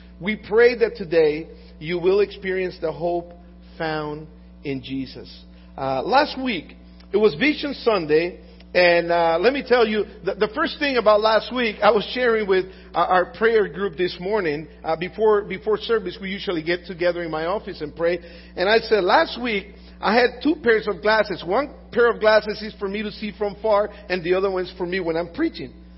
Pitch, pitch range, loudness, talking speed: 195 Hz, 170-215 Hz, -21 LUFS, 200 wpm